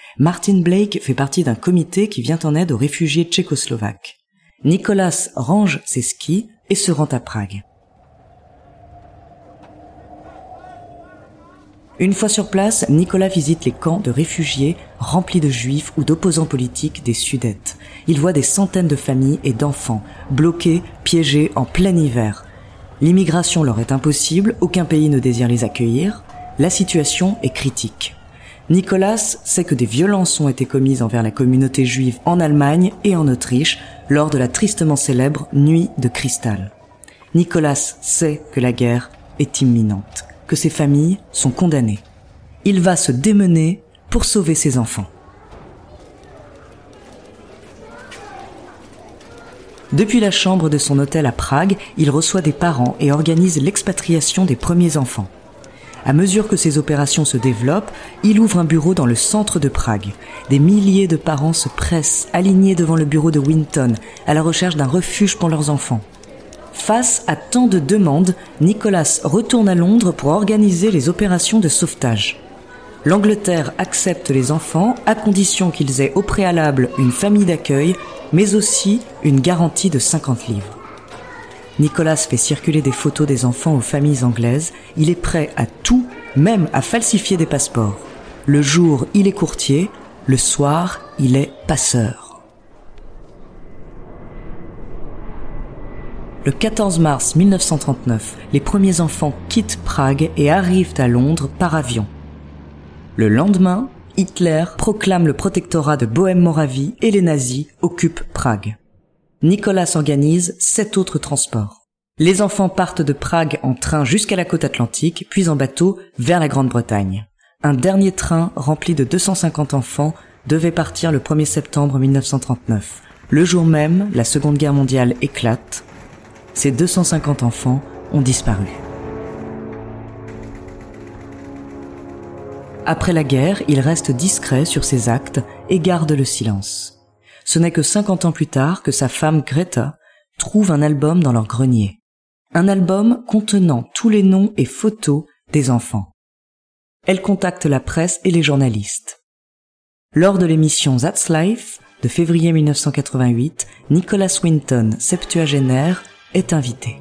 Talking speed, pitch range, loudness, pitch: 140 wpm, 130-180 Hz, -16 LUFS, 150 Hz